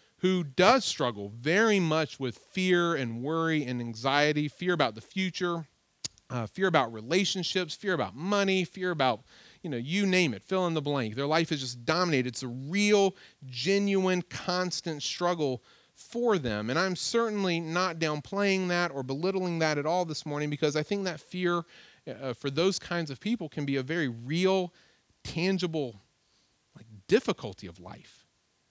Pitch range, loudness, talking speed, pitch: 140-185 Hz, -29 LUFS, 165 wpm, 165 Hz